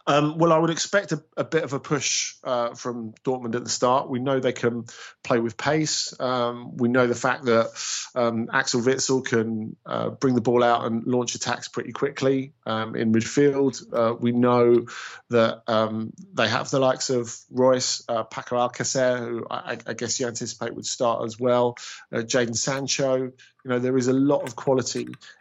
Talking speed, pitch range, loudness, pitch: 195 wpm, 115-135 Hz, -24 LUFS, 125 Hz